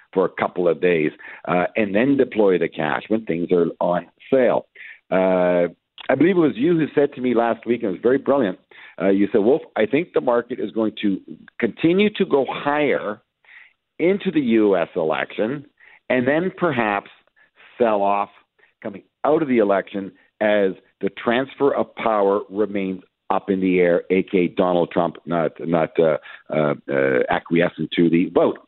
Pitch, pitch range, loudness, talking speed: 100 Hz, 90-125 Hz, -20 LUFS, 175 wpm